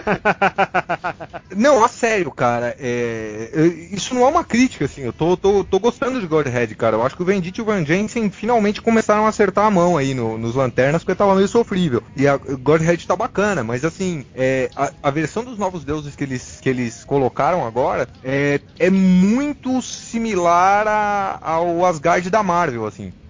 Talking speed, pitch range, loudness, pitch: 185 wpm, 135-205 Hz, -18 LUFS, 175 Hz